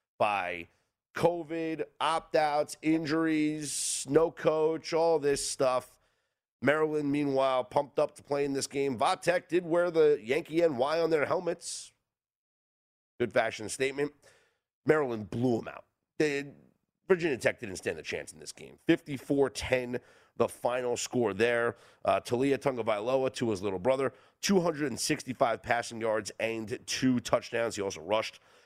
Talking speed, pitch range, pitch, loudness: 140 wpm, 120-160 Hz, 140 Hz, -30 LUFS